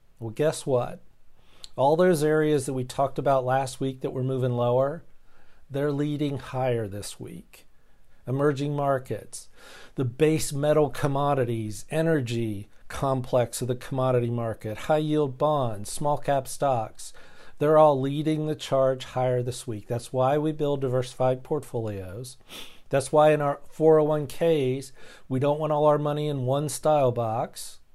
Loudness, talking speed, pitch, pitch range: -25 LUFS, 145 wpm, 135 Hz, 125-150 Hz